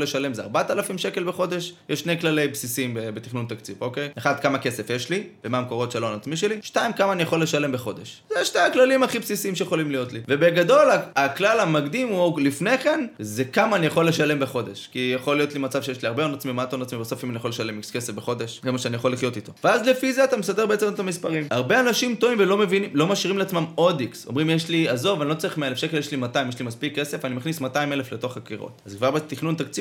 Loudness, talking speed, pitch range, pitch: -23 LUFS, 190 wpm, 125-190 Hz, 145 Hz